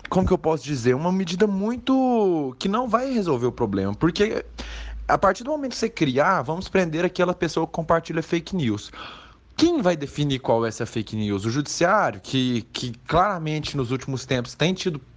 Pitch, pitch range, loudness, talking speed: 160 Hz, 125-190 Hz, -23 LUFS, 190 wpm